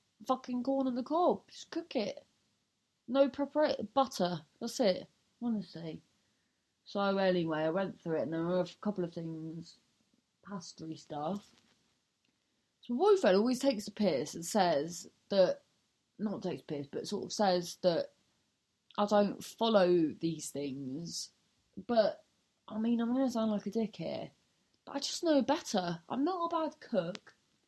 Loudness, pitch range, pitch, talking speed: -33 LUFS, 175-260 Hz, 205 Hz, 165 wpm